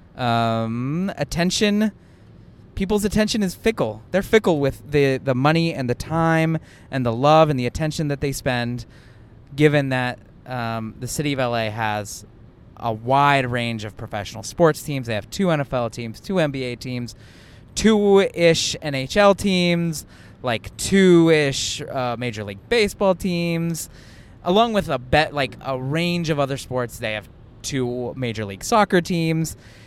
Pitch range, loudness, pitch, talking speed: 115-165 Hz, -21 LUFS, 135 Hz, 155 wpm